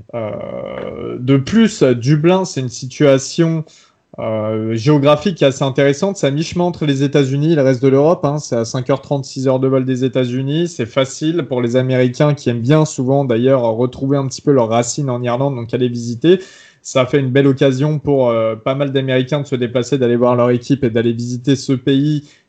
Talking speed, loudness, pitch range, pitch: 195 wpm, -15 LUFS, 125-150 Hz, 135 Hz